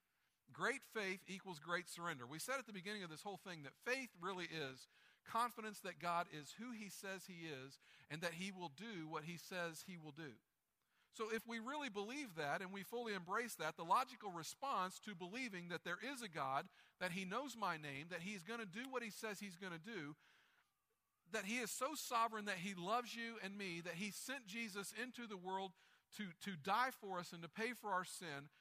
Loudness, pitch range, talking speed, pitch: -47 LUFS, 175-230 Hz, 220 wpm, 195 Hz